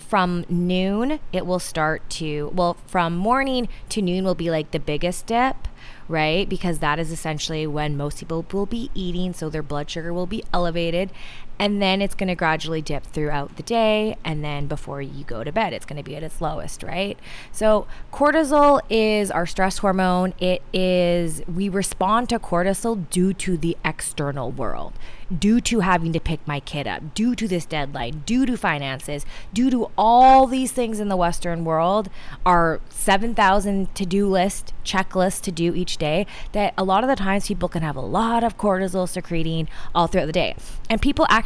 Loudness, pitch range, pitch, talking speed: -22 LUFS, 160-205 Hz, 180 Hz, 190 wpm